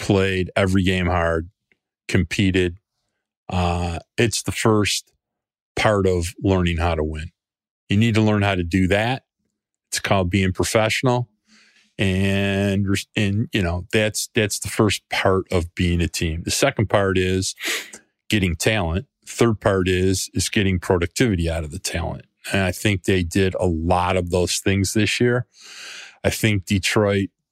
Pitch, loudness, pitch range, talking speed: 95 Hz, -21 LUFS, 90-105 Hz, 155 wpm